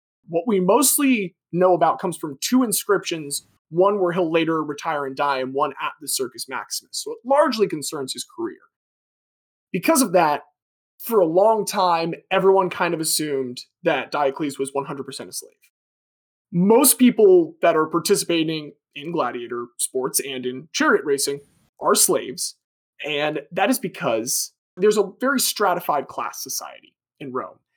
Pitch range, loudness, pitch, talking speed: 145-225 Hz, -21 LUFS, 175 Hz, 155 wpm